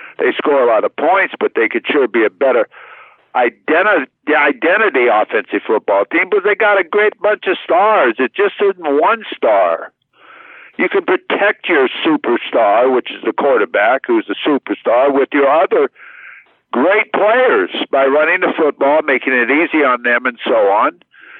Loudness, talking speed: -14 LUFS, 170 wpm